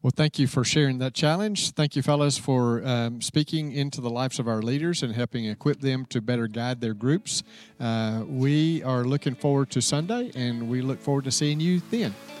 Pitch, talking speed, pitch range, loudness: 135 Hz, 210 wpm, 125-150 Hz, -26 LUFS